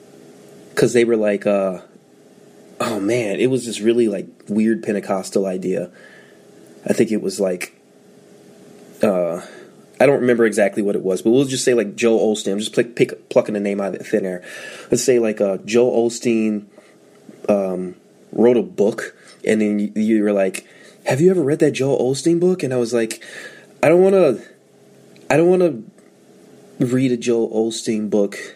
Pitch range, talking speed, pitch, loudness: 105-125 Hz, 185 wpm, 110 Hz, -18 LUFS